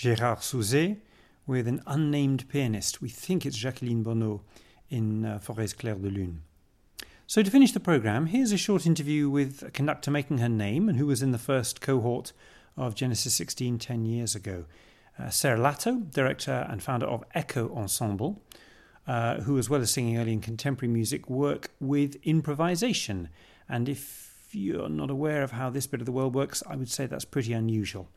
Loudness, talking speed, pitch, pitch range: -28 LUFS, 185 wpm, 130 Hz, 115-145 Hz